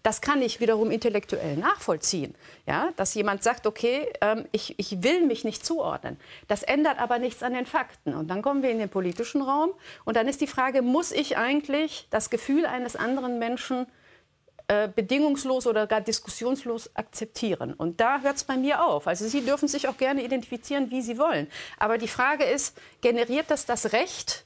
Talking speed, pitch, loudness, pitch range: 185 wpm, 245 Hz, -26 LUFS, 220-280 Hz